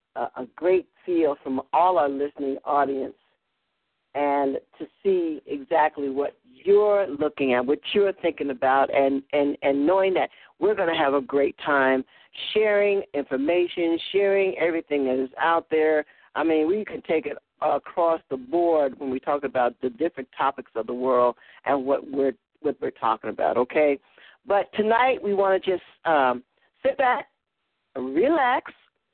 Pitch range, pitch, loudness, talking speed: 135-185 Hz, 150 Hz, -24 LUFS, 160 wpm